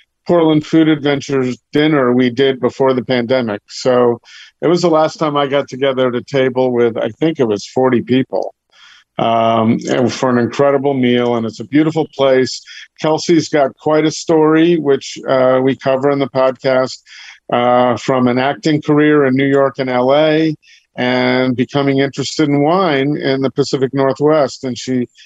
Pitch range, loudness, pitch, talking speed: 125-150 Hz, -14 LUFS, 135 Hz, 170 wpm